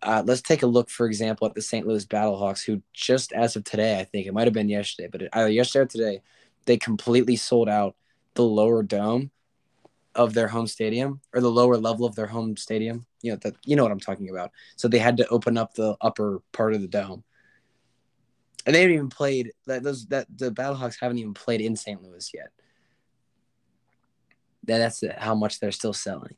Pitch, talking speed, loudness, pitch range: 115 Hz, 215 wpm, -24 LUFS, 110-120 Hz